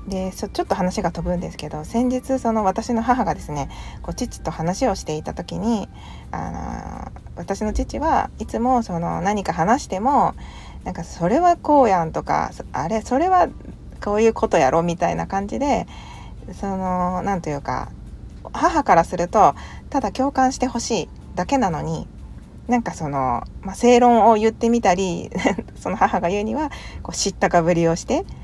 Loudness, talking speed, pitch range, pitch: -21 LUFS, 305 characters per minute, 170-240 Hz, 195 Hz